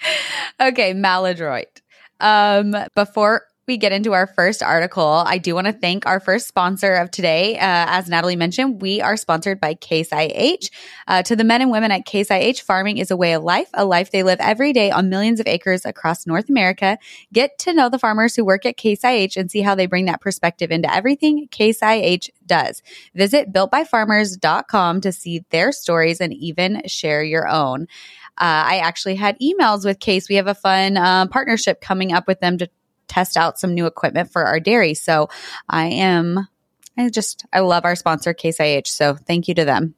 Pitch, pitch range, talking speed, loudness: 190 Hz, 175-210 Hz, 195 wpm, -17 LUFS